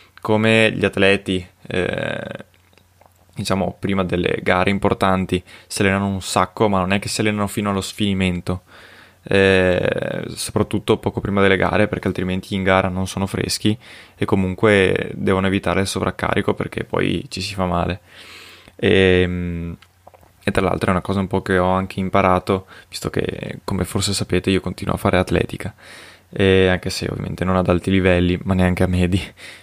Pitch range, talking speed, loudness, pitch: 90-100 Hz, 165 wpm, -19 LUFS, 95 Hz